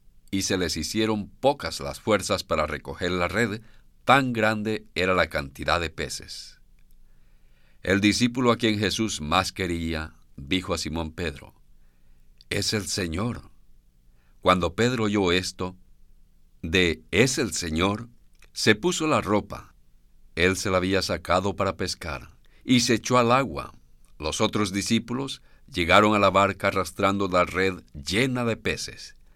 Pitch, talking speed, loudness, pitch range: 90 Hz, 140 wpm, -24 LUFS, 70-105 Hz